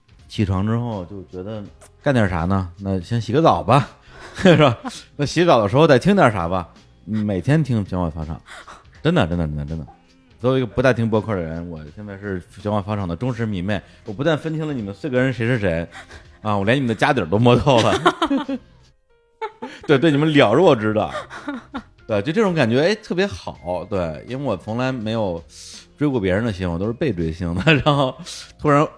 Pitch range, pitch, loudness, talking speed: 90-145 Hz, 110 Hz, -19 LUFS, 290 characters per minute